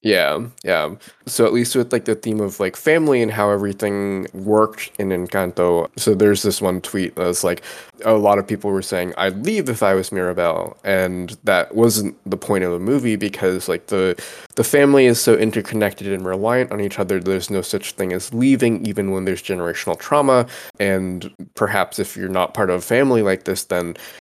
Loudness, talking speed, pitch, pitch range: -19 LUFS, 205 wpm, 100 Hz, 95-110 Hz